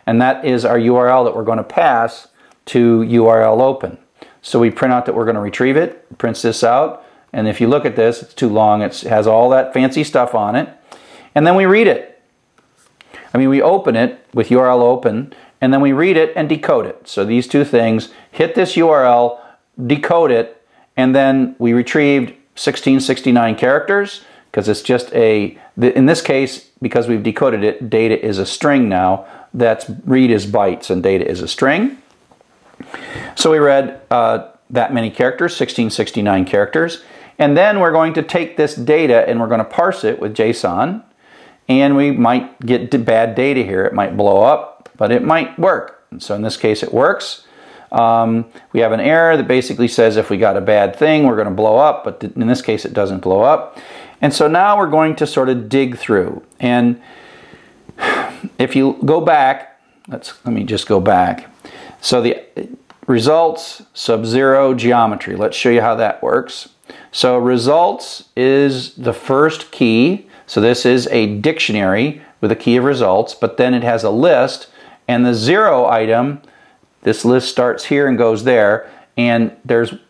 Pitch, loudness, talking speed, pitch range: 120 Hz, -14 LUFS, 185 wpm, 115-135 Hz